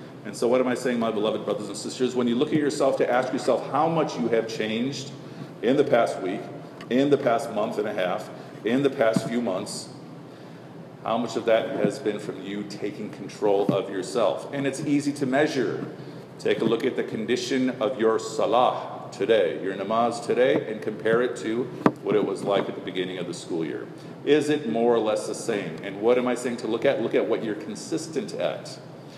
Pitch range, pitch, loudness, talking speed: 110-145 Hz, 130 Hz, -25 LUFS, 220 wpm